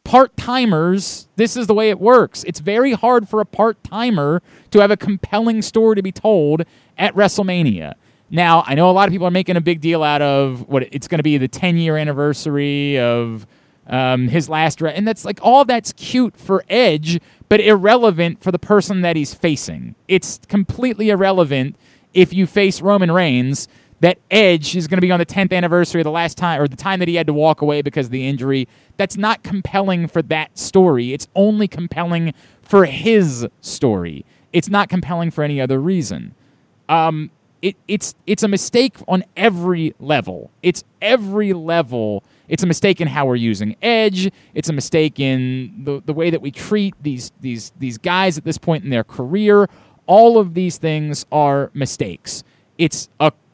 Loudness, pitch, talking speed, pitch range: -16 LUFS, 170 Hz, 190 wpm, 150-200 Hz